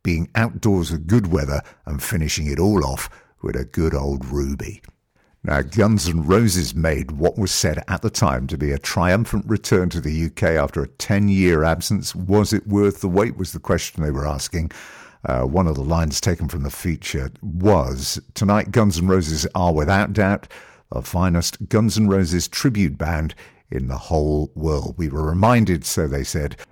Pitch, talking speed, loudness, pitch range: 90 Hz, 185 wpm, -20 LUFS, 75-100 Hz